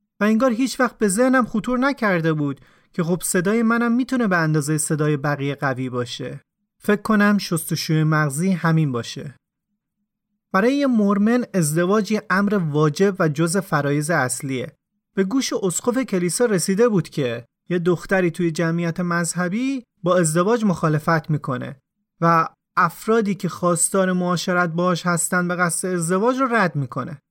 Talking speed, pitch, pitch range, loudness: 145 wpm, 180 Hz, 160-210 Hz, -20 LUFS